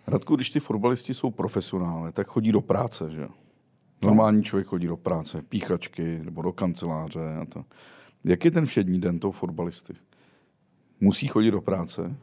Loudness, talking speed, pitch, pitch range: -26 LUFS, 160 wpm, 95 Hz, 85-115 Hz